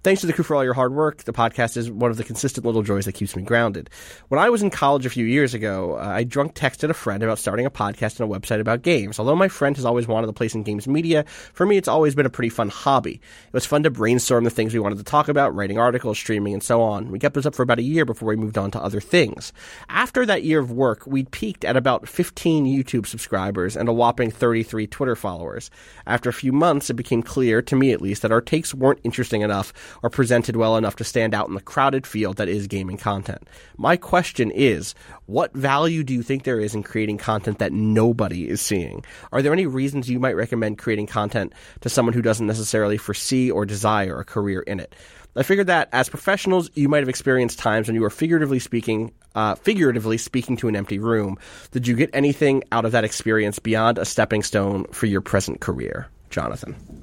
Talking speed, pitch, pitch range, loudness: 240 wpm, 115 Hz, 105-135 Hz, -21 LUFS